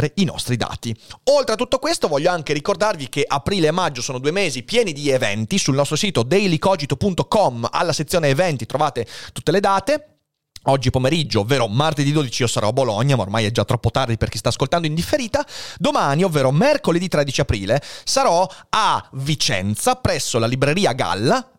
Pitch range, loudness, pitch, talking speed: 125-185 Hz, -19 LUFS, 150 Hz, 180 wpm